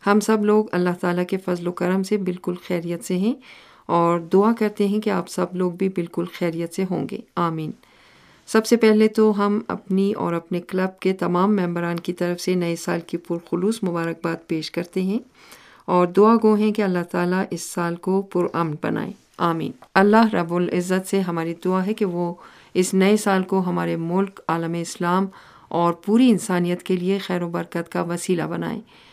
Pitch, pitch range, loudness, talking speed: 185 Hz, 175-200 Hz, -22 LUFS, 190 wpm